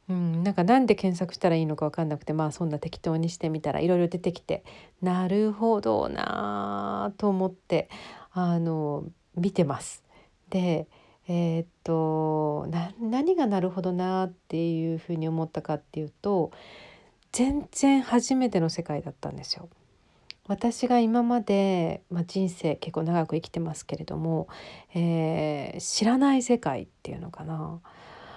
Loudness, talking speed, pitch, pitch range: -27 LUFS, 290 characters per minute, 170 Hz, 160-195 Hz